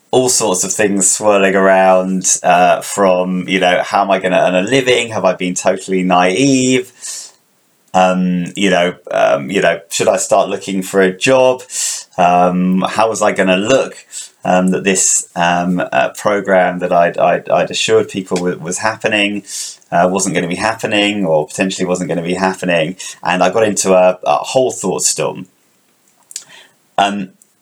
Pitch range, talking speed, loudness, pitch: 90-100 Hz, 175 wpm, -13 LUFS, 95 Hz